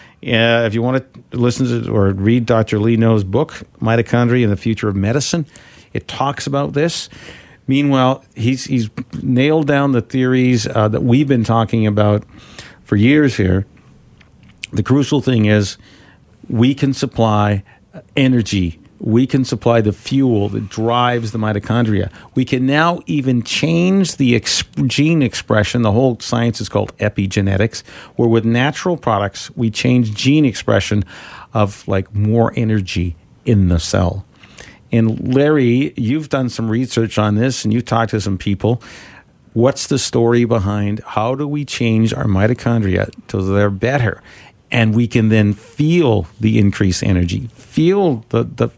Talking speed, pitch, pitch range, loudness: 155 wpm, 115 Hz, 105-130 Hz, -16 LUFS